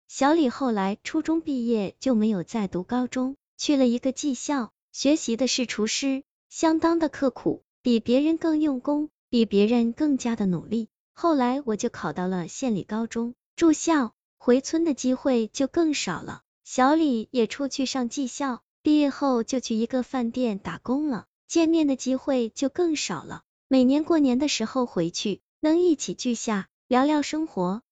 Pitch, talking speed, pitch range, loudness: 255 Hz, 245 characters per minute, 230-290 Hz, -25 LUFS